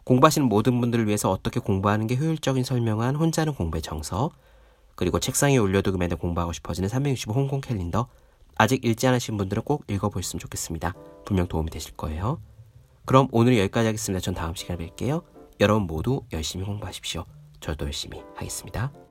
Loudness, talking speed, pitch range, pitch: -25 LUFS, 440 characters per minute, 90-130 Hz, 105 Hz